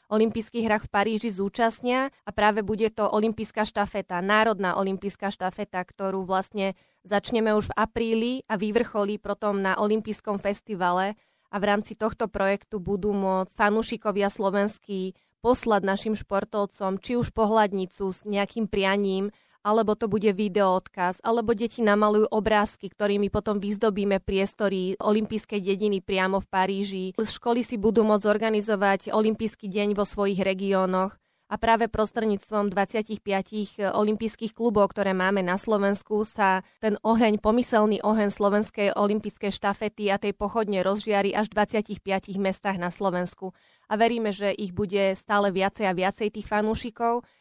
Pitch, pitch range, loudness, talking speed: 205 Hz, 195-215 Hz, -26 LUFS, 140 wpm